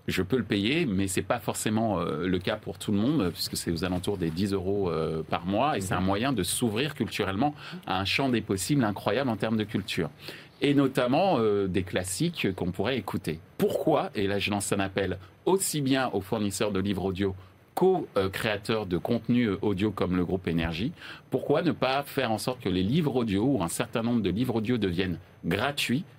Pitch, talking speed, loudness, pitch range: 105 Hz, 210 wpm, -28 LUFS, 95-125 Hz